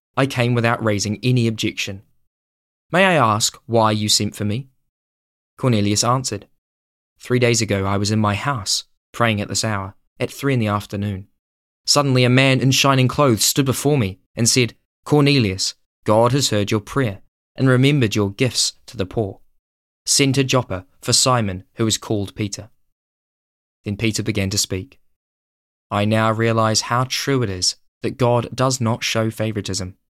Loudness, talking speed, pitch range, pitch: -19 LUFS, 165 wpm, 95-125 Hz, 110 Hz